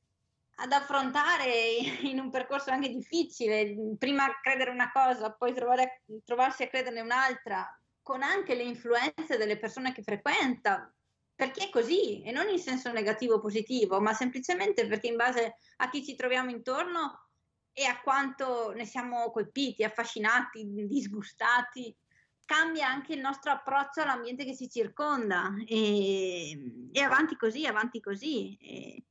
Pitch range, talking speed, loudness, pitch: 225-275 Hz, 140 wpm, -30 LUFS, 250 Hz